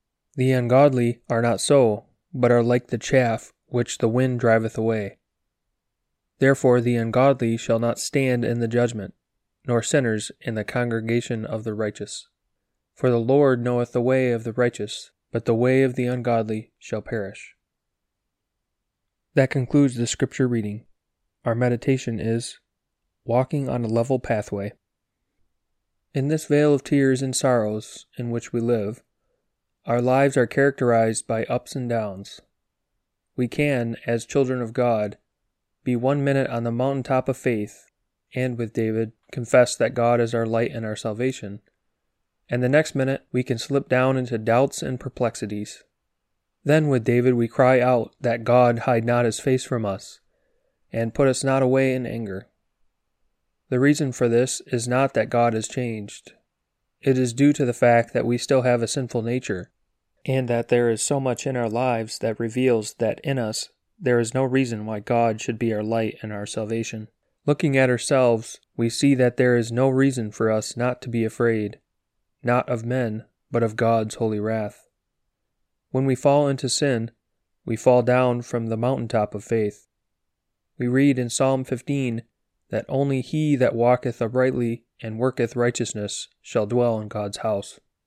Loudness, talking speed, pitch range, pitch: -22 LUFS, 170 wpm, 115-130 Hz, 120 Hz